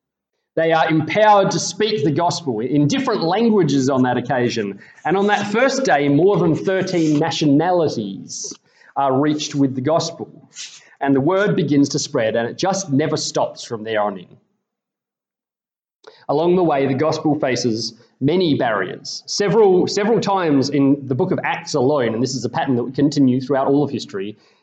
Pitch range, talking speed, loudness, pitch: 135-185 Hz, 175 wpm, -18 LUFS, 150 Hz